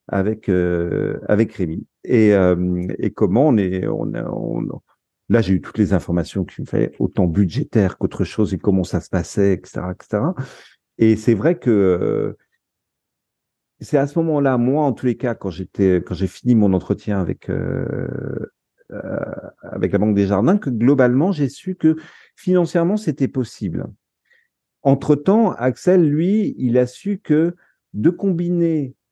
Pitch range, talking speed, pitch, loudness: 95-150 Hz, 165 wpm, 115 Hz, -19 LUFS